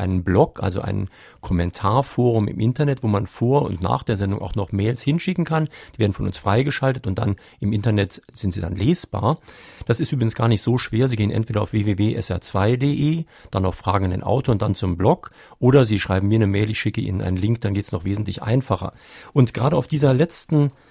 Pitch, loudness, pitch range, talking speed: 110 Hz, -21 LUFS, 100-130 Hz, 220 wpm